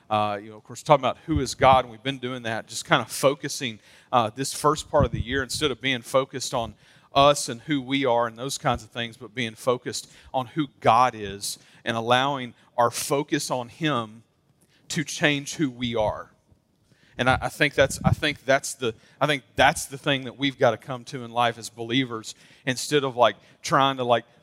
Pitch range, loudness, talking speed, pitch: 115-140 Hz, -24 LUFS, 220 wpm, 130 Hz